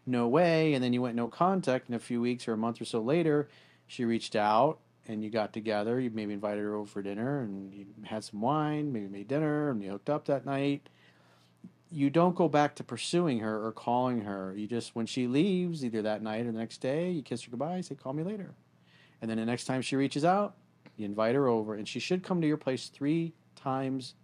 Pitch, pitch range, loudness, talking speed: 120 Hz, 110-145 Hz, -31 LUFS, 240 wpm